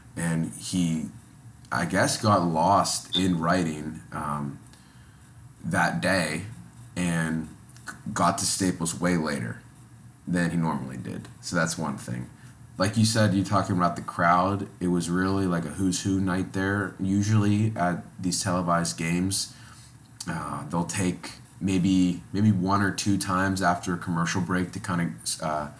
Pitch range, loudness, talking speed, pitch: 85-95 Hz, -26 LUFS, 150 wpm, 90 Hz